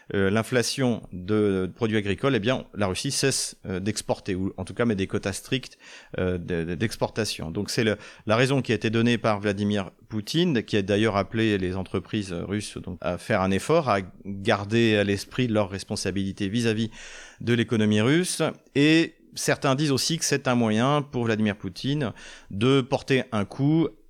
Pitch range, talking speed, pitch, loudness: 100-125 Hz, 170 wpm, 110 Hz, -25 LUFS